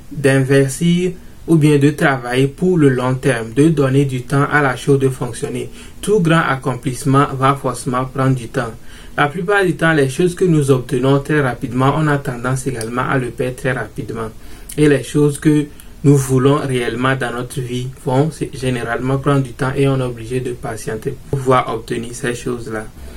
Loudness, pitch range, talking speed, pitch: -16 LUFS, 125-145 Hz, 185 wpm, 135 Hz